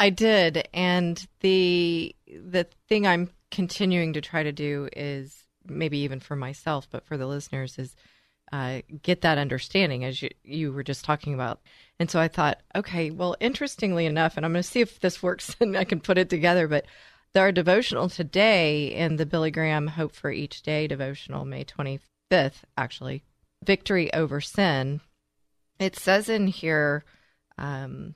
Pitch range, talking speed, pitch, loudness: 140-180 Hz, 170 wpm, 160 Hz, -26 LUFS